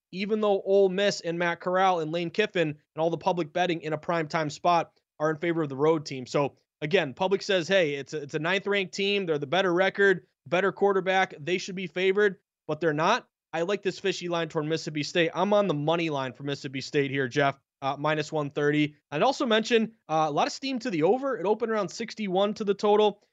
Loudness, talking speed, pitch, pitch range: -27 LUFS, 230 wpm, 175 Hz, 155-200 Hz